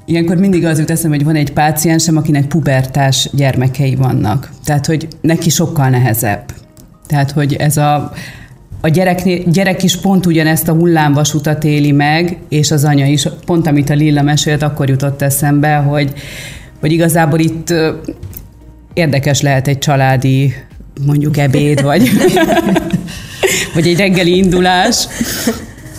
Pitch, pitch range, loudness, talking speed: 150 Hz, 140-165 Hz, -12 LUFS, 135 wpm